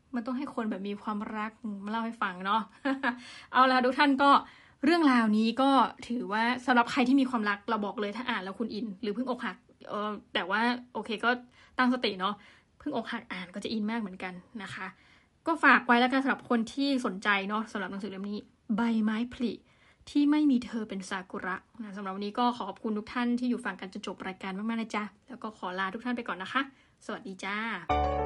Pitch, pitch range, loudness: 225 Hz, 205-245 Hz, -30 LUFS